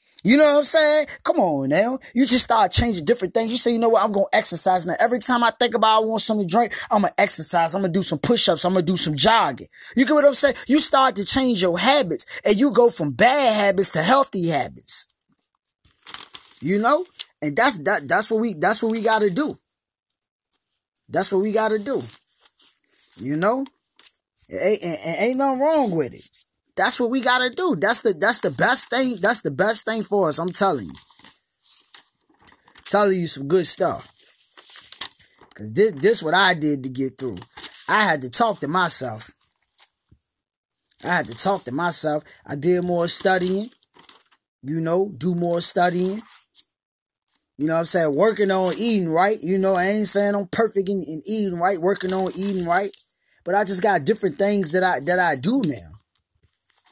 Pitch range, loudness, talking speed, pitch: 175-235 Hz, -17 LUFS, 195 wpm, 200 Hz